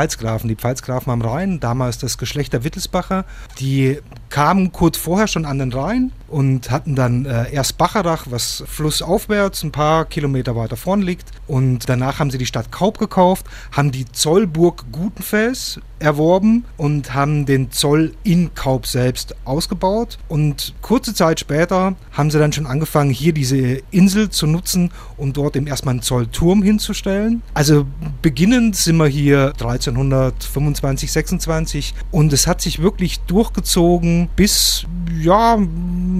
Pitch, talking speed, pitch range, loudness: 150 Hz, 150 wpm, 130-180 Hz, -17 LUFS